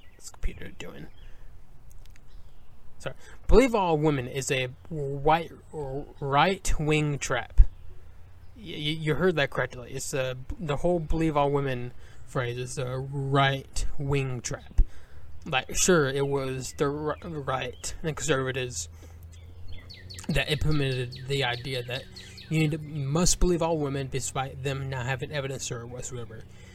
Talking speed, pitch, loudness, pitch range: 130 wpm, 135 Hz, -28 LUFS, 110-145 Hz